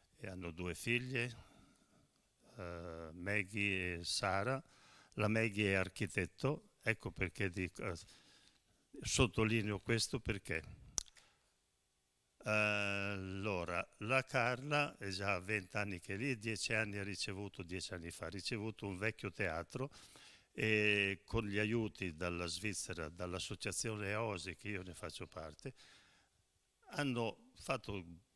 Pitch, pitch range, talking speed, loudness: 100 Hz, 95-110 Hz, 110 wpm, -40 LUFS